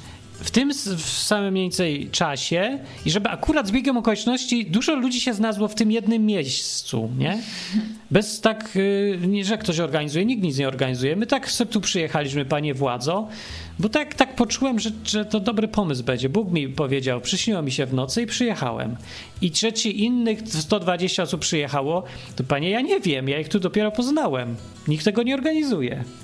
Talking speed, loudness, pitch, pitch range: 175 wpm, -23 LUFS, 195 Hz, 150-225 Hz